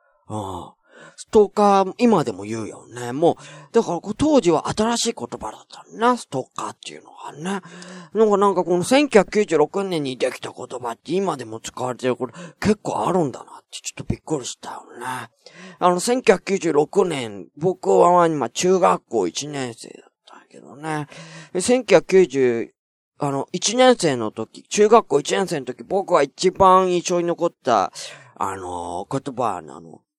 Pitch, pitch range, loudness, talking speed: 175 Hz, 135-200 Hz, -20 LUFS, 280 characters per minute